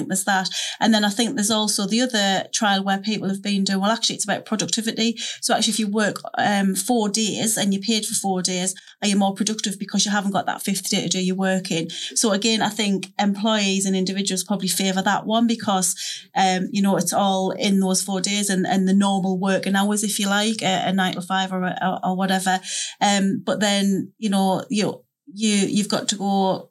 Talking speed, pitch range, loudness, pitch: 225 wpm, 190-215 Hz, -21 LUFS, 200 Hz